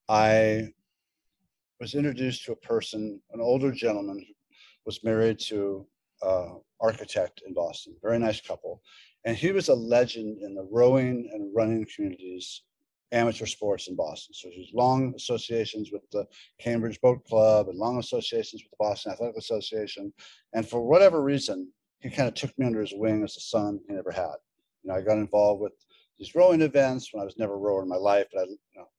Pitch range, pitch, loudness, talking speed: 105-130 Hz, 110 Hz, -27 LUFS, 190 wpm